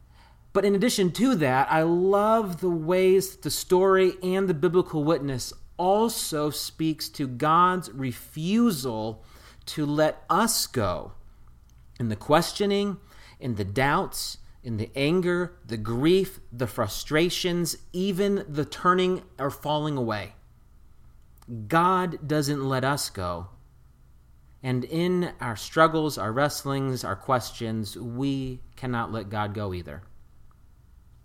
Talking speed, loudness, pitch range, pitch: 120 wpm, -25 LUFS, 120-180 Hz, 145 Hz